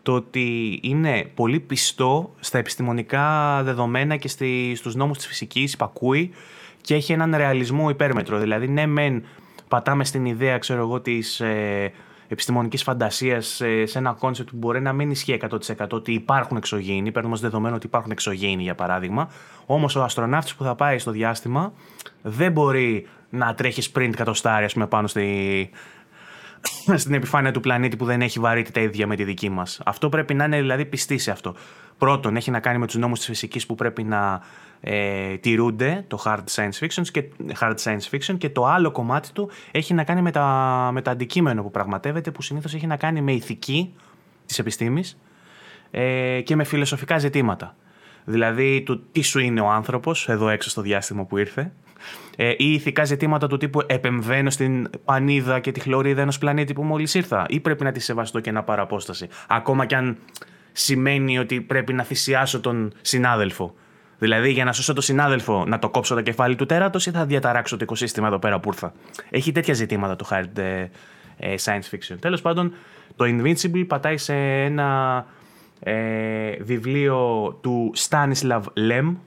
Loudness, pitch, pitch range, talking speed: -22 LUFS, 125 Hz, 110-145 Hz, 175 wpm